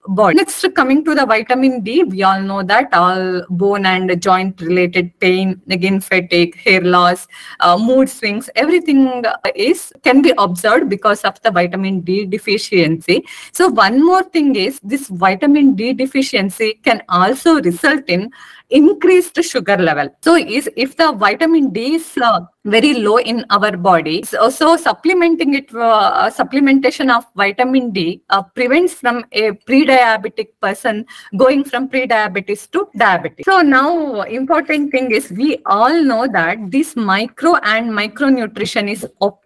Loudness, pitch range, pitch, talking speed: -14 LUFS, 195-280 Hz, 230 Hz, 150 wpm